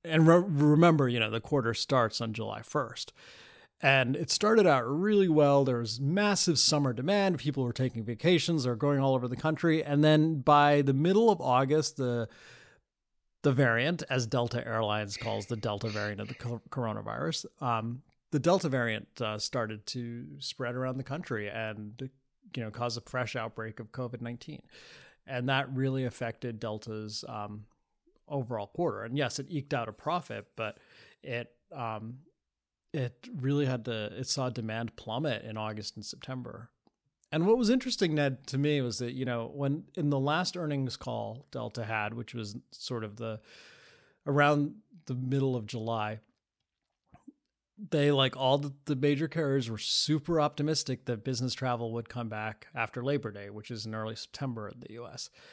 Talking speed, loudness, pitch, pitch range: 175 wpm, -30 LUFS, 130 Hz, 115-145 Hz